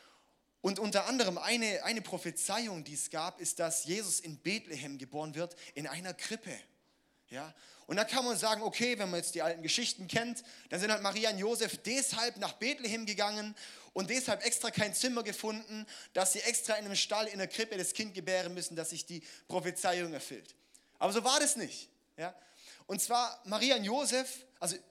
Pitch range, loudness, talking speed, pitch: 180-230 Hz, -34 LUFS, 190 wpm, 205 Hz